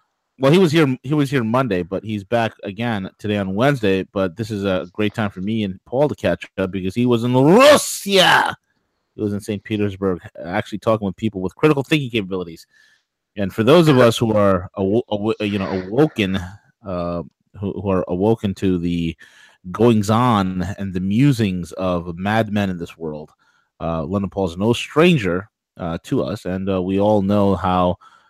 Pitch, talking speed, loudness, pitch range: 100 Hz, 190 wpm, -19 LUFS, 95-115 Hz